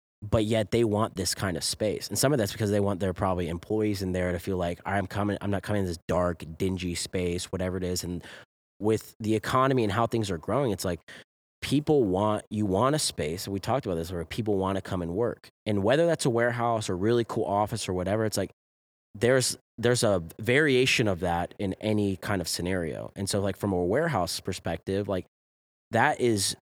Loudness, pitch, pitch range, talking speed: -28 LUFS, 100 Hz, 90-110 Hz, 220 wpm